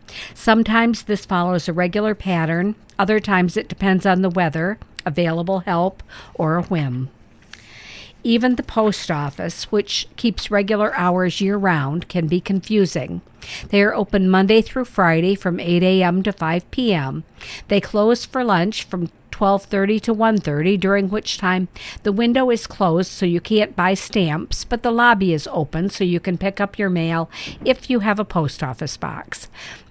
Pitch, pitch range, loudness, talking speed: 190 Hz, 175-215 Hz, -19 LUFS, 165 wpm